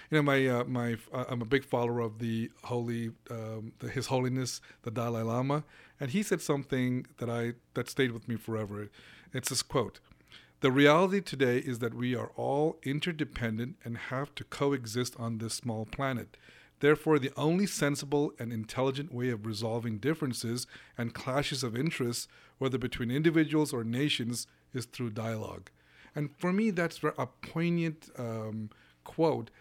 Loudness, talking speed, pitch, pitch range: -32 LUFS, 165 wpm, 125 Hz, 115-145 Hz